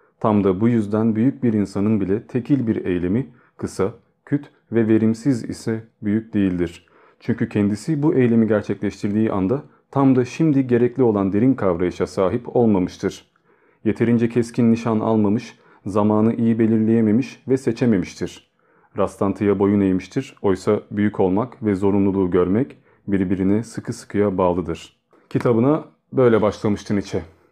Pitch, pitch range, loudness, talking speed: 110 Hz, 100-120 Hz, -20 LUFS, 130 wpm